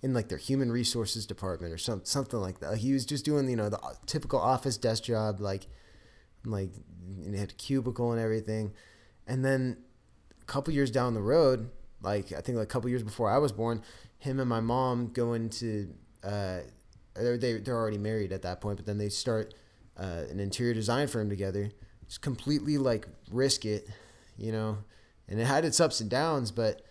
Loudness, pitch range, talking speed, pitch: -31 LUFS, 105-125 Hz, 200 wpm, 110 Hz